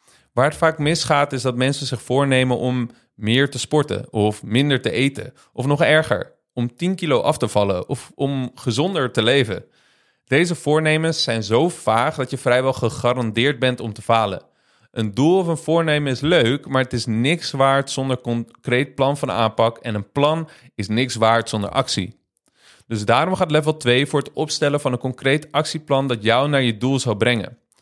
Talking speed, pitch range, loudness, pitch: 190 wpm, 115-145 Hz, -20 LUFS, 130 Hz